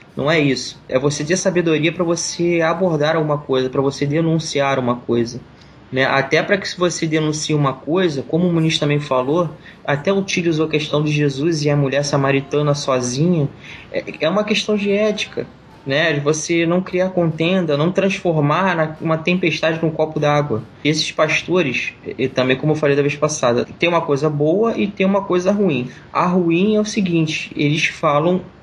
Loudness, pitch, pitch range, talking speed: -18 LUFS, 155 Hz, 145-175 Hz, 180 wpm